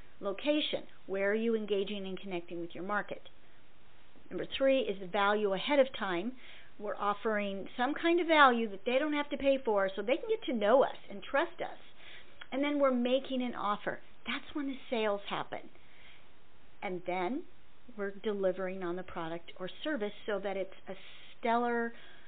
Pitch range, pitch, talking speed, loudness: 195-270 Hz, 210 Hz, 180 wpm, -33 LUFS